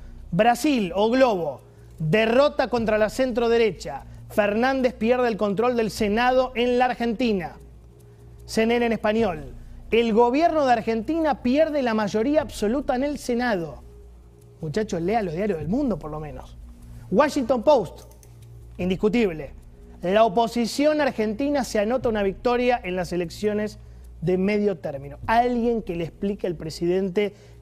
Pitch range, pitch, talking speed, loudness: 170-245 Hz, 215 Hz, 135 wpm, -23 LUFS